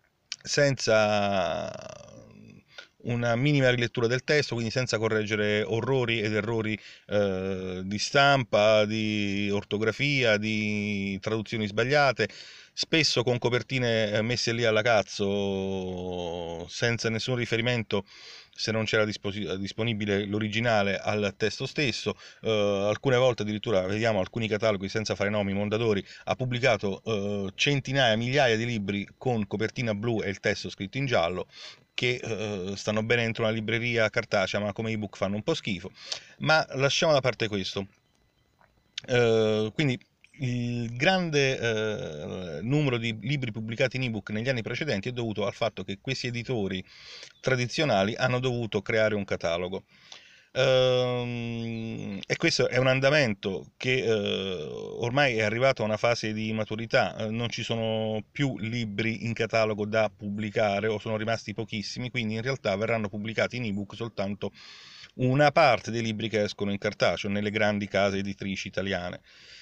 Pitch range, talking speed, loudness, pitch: 105-125 Hz, 140 wpm, -27 LUFS, 110 Hz